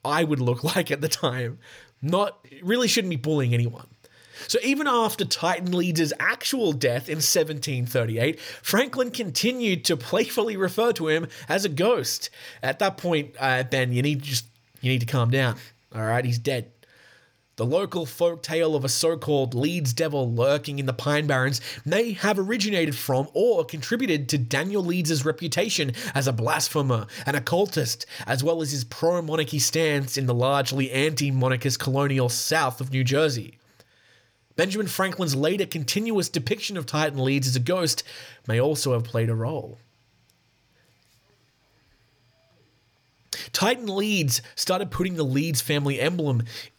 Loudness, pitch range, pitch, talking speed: -24 LUFS, 125-170 Hz, 145 Hz, 155 wpm